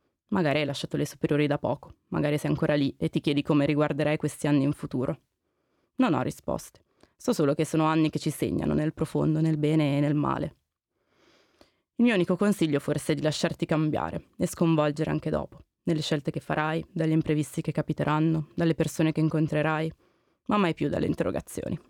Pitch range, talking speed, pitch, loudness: 150-160 Hz, 185 wpm, 155 Hz, -27 LUFS